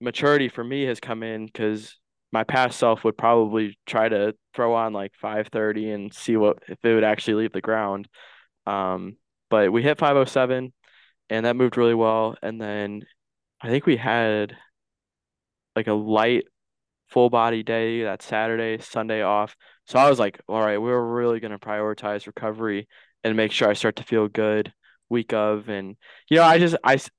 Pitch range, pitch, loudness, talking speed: 105-120 Hz, 110 Hz, -23 LUFS, 185 wpm